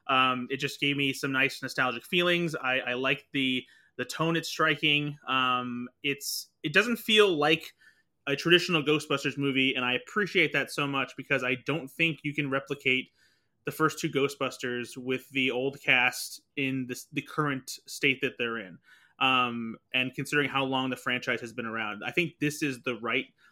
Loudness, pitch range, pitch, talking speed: -28 LUFS, 125-150 Hz, 135 Hz, 185 wpm